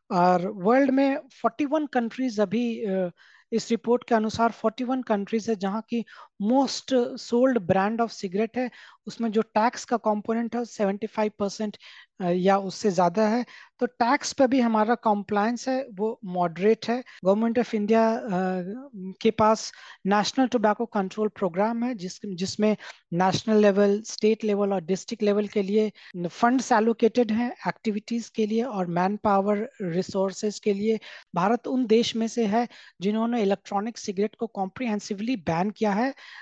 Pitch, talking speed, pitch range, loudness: 220 Hz, 150 wpm, 200-235 Hz, -25 LUFS